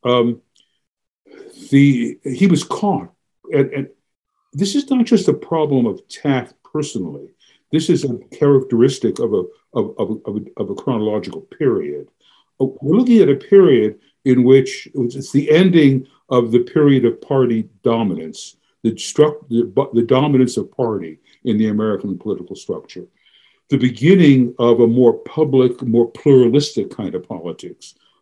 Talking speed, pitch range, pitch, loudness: 150 wpm, 125-170 Hz, 140 Hz, -16 LUFS